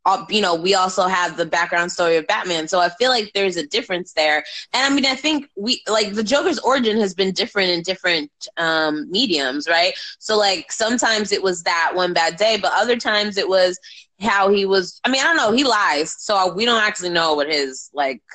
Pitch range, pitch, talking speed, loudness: 170-220 Hz, 190 Hz, 225 wpm, -18 LUFS